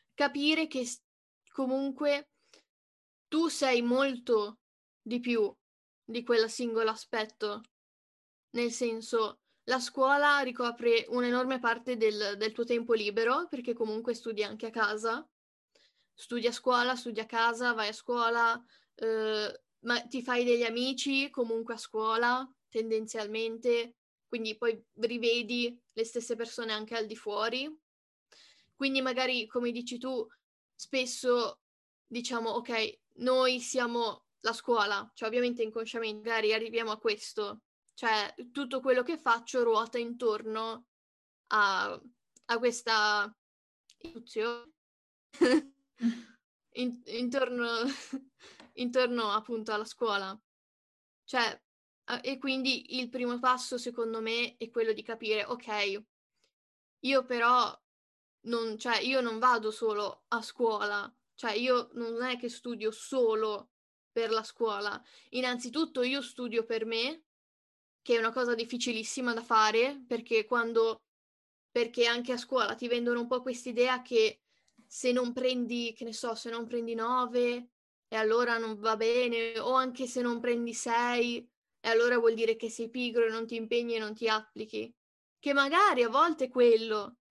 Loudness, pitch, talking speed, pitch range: -31 LUFS, 235 Hz, 130 wpm, 225-250 Hz